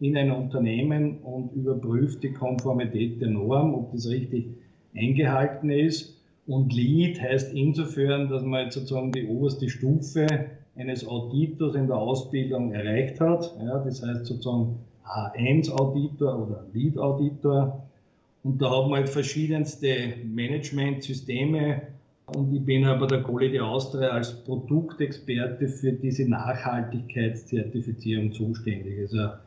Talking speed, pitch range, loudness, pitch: 120 wpm, 120-140 Hz, -27 LUFS, 130 Hz